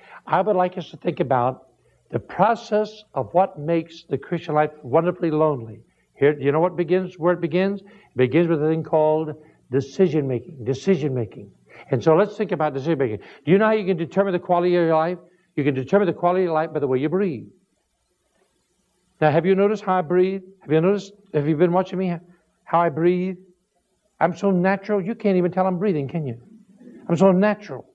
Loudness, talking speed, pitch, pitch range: -21 LUFS, 215 wpm, 175 Hz, 155-190 Hz